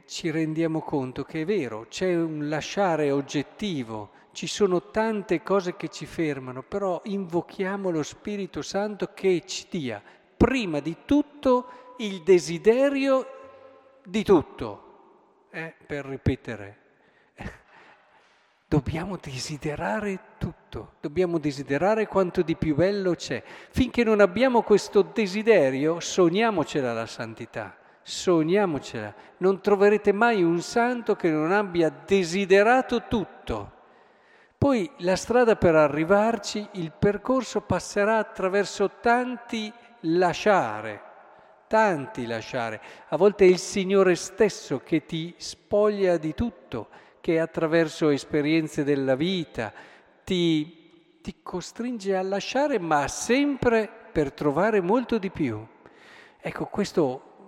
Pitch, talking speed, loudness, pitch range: 185 Hz, 110 wpm, -25 LUFS, 155-215 Hz